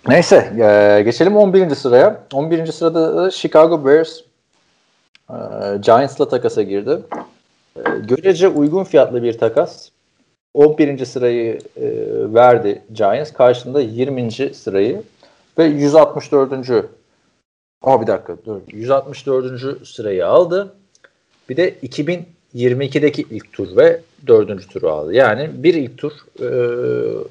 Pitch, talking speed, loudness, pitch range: 150 Hz, 100 wpm, -15 LUFS, 130-195 Hz